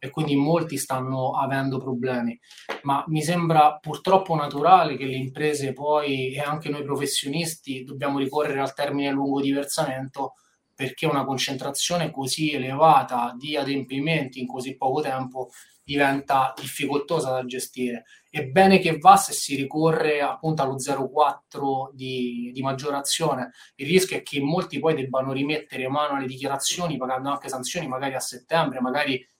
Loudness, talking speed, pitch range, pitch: -24 LUFS, 145 wpm, 130-150 Hz, 140 Hz